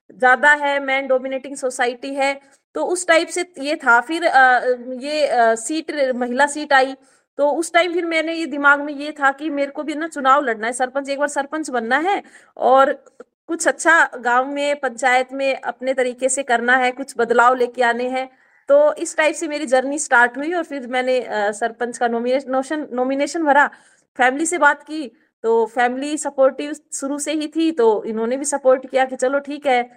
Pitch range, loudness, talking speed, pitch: 255-295 Hz, -18 LUFS, 190 wpm, 275 Hz